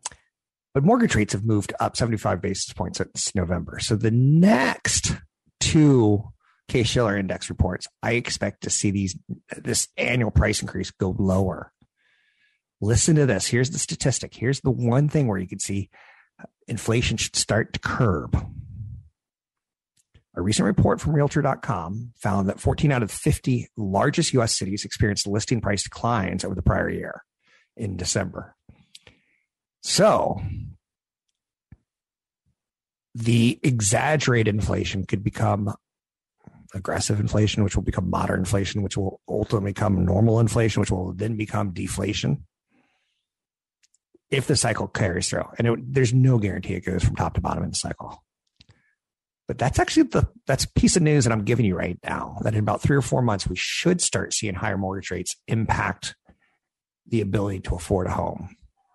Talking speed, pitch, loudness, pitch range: 155 wpm, 110 Hz, -23 LUFS, 100-125 Hz